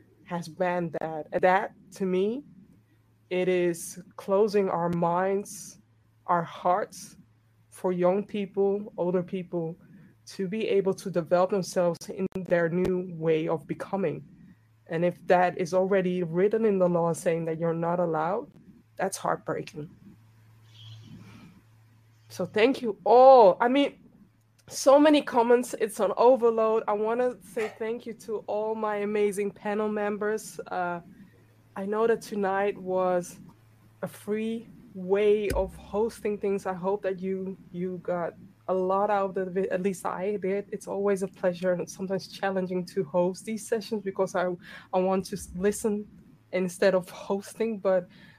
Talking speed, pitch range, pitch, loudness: 150 wpm, 175-205 Hz, 190 Hz, -27 LUFS